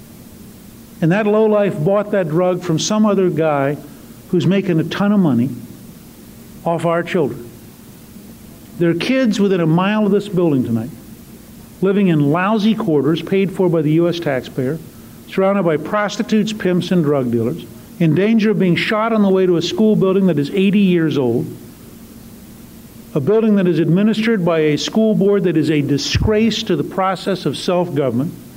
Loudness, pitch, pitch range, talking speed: -16 LUFS, 180 Hz, 160-205 Hz, 170 wpm